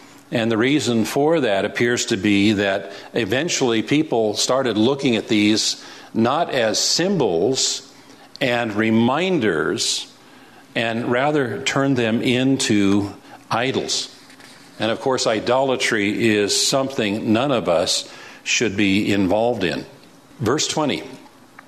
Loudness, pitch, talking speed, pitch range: -19 LUFS, 115 Hz, 115 wpm, 105-135 Hz